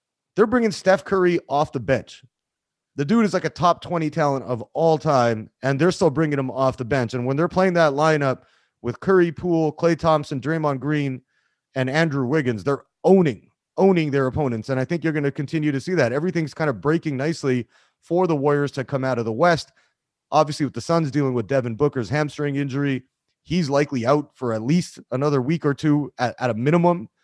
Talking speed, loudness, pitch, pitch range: 210 wpm, -21 LUFS, 145 Hz, 135-165 Hz